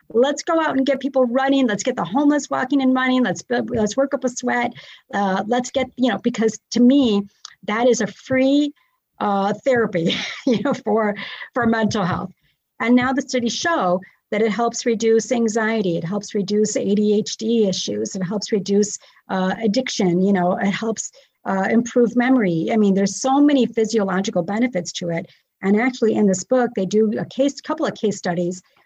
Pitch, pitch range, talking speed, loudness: 225 Hz, 200-255 Hz, 185 wpm, -20 LUFS